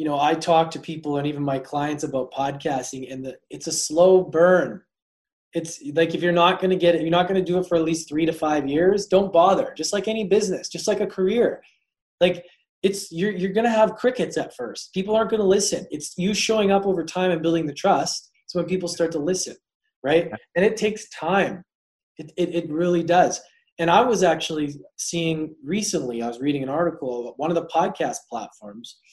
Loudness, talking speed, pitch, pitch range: -22 LUFS, 225 wpm, 170 Hz, 160-190 Hz